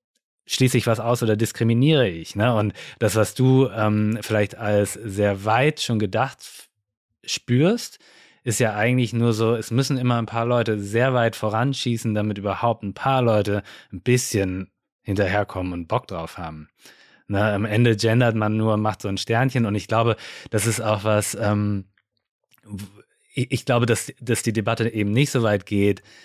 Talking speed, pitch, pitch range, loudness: 175 wpm, 110 Hz, 105-120 Hz, -22 LUFS